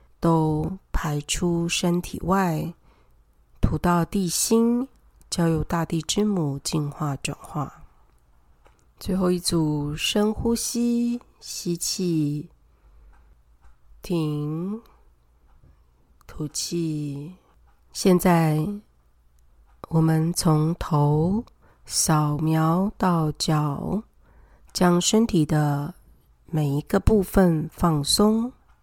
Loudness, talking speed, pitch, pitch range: -23 LUFS, 110 characters per minute, 160 Hz, 145-180 Hz